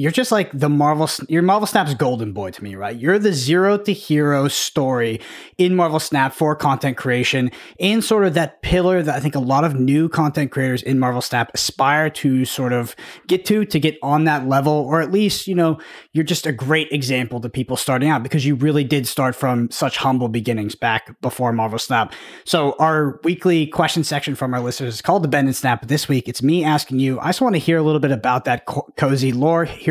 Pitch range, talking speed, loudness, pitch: 130-160 Hz, 230 wpm, -18 LUFS, 145 Hz